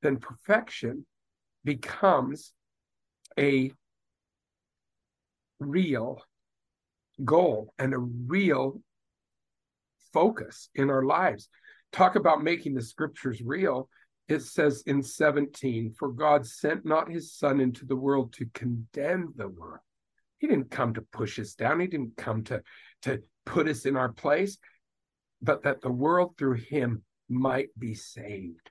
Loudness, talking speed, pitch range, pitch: -28 LUFS, 130 wpm, 115-150 Hz, 135 Hz